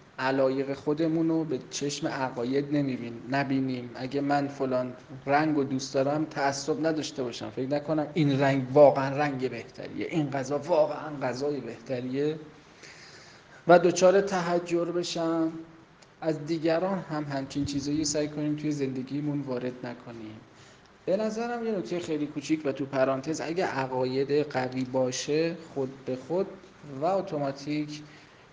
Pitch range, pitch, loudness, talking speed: 130-155 Hz, 145 Hz, -28 LUFS, 135 wpm